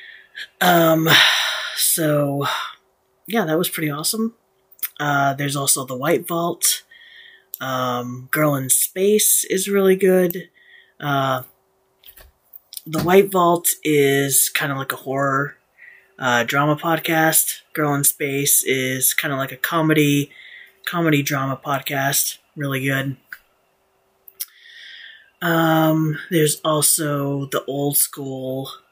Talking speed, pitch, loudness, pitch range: 110 wpm, 150 Hz, -18 LUFS, 140-170 Hz